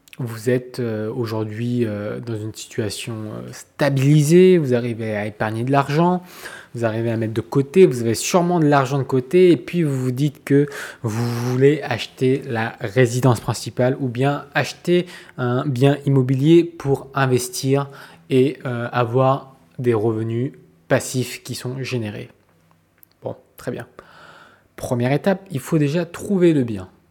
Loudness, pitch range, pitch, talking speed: -20 LUFS, 115-145 Hz, 130 Hz, 145 wpm